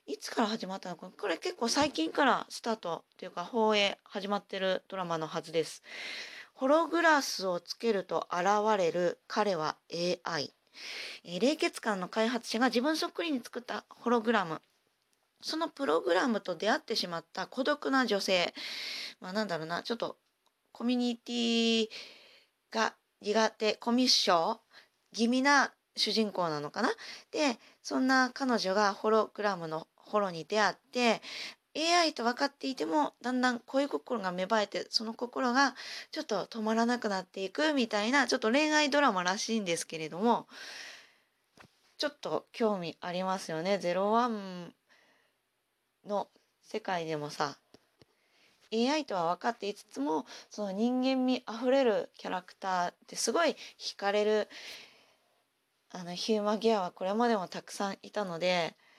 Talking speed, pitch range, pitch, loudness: 310 characters per minute, 185-255 Hz, 220 Hz, -31 LUFS